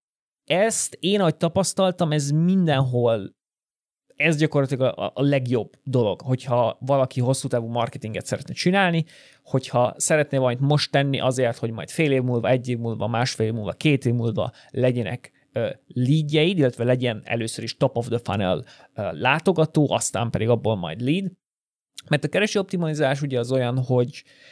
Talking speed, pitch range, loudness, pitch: 145 wpm, 120-150 Hz, -23 LUFS, 130 Hz